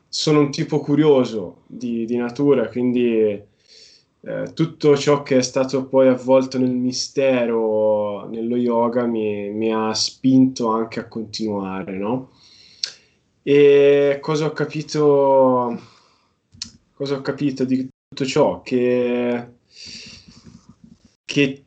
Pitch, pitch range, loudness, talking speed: 125 Hz, 115-140 Hz, -19 LUFS, 110 wpm